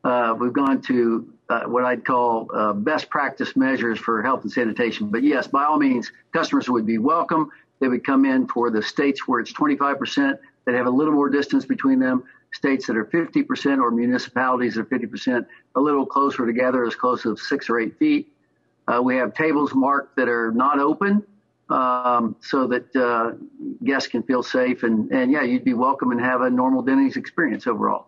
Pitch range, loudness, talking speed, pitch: 120-155 Hz, -21 LUFS, 200 wpm, 130 Hz